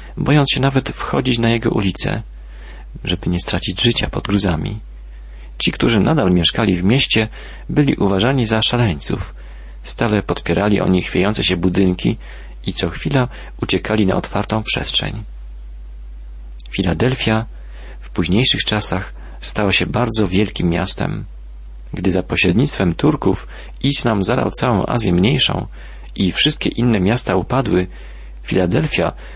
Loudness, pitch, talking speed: -16 LUFS, 95 Hz, 125 wpm